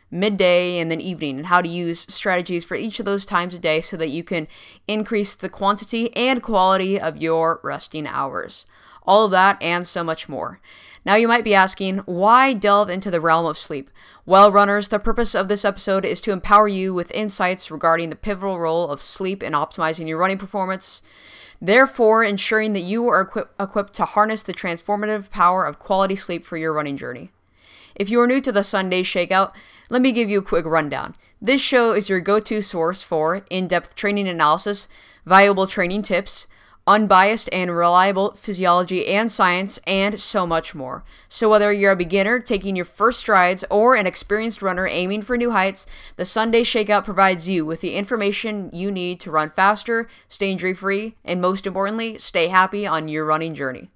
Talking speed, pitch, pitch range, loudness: 190 wpm, 190 Hz, 175-210 Hz, -19 LUFS